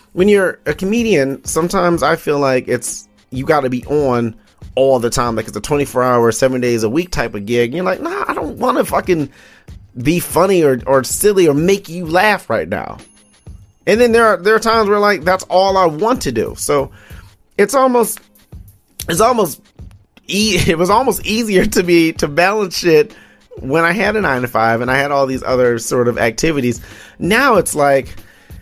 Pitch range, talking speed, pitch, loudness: 120-185 Hz, 205 wpm, 145 Hz, -14 LUFS